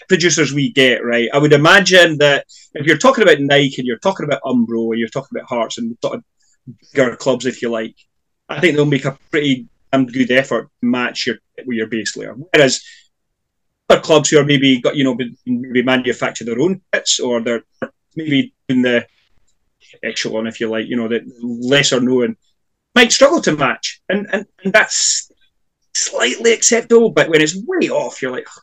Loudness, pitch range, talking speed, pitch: -15 LUFS, 120-180 Hz, 195 wpm, 135 Hz